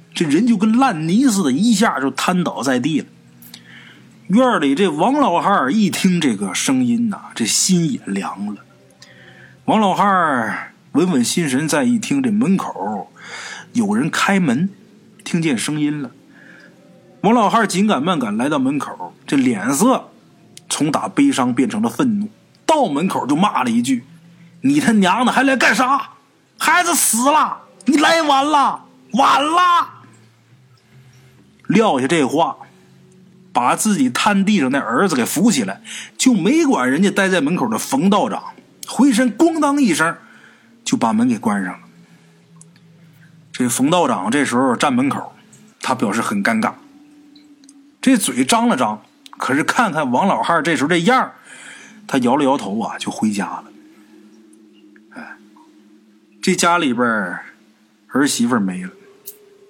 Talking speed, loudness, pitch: 205 characters per minute, -17 LUFS, 215 Hz